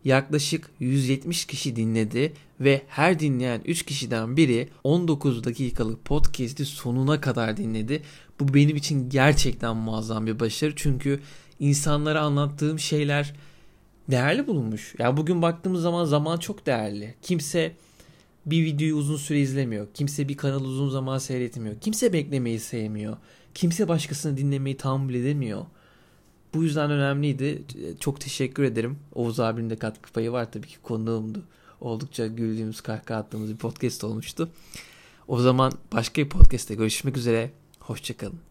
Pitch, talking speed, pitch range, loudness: 135 Hz, 135 wpm, 115-150 Hz, -26 LUFS